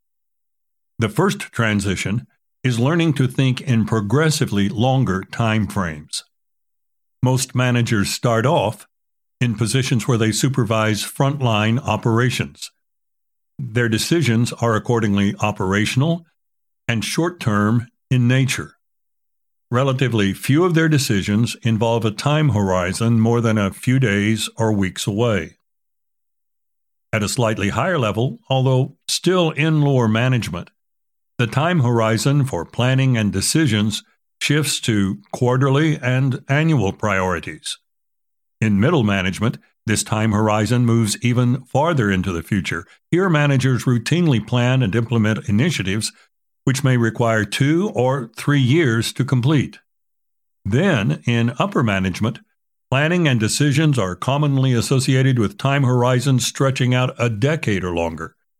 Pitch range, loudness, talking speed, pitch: 110-135 Hz, -19 LUFS, 125 wpm, 120 Hz